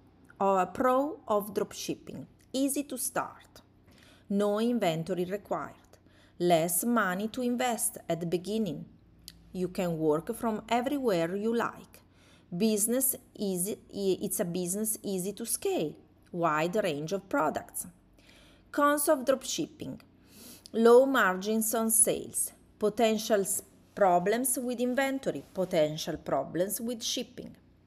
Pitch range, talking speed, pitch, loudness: 180-245 Hz, 110 wpm, 215 Hz, -29 LUFS